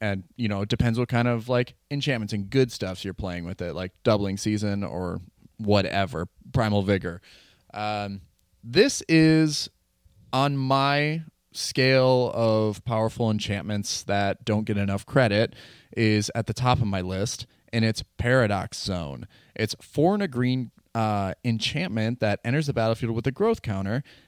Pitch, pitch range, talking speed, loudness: 110 Hz, 100-125 Hz, 160 wpm, -25 LUFS